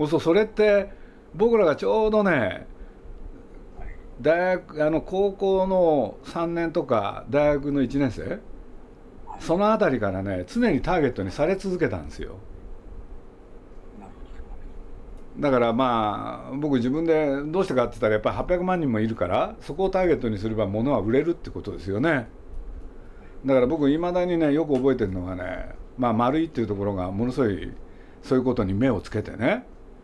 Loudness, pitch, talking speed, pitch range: -24 LUFS, 130 Hz, 315 characters per minute, 100-170 Hz